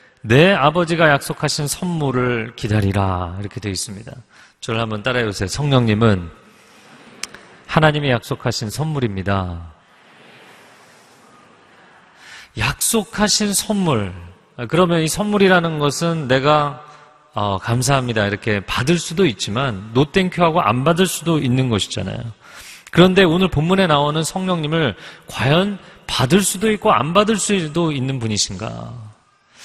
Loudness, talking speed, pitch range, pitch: -17 LUFS, 280 characters per minute, 110-170 Hz, 140 Hz